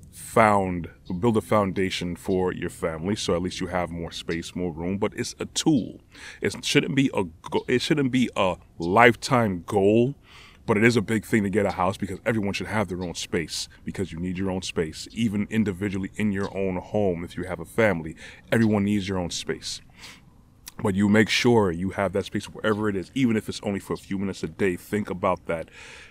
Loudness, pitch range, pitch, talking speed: -25 LUFS, 90-110 Hz, 100 Hz, 215 wpm